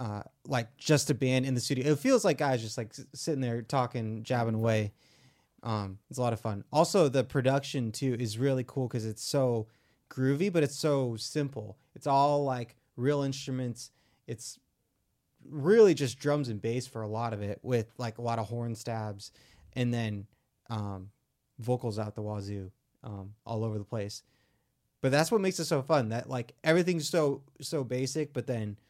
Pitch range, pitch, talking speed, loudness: 110-140 Hz, 125 Hz, 185 wpm, -31 LUFS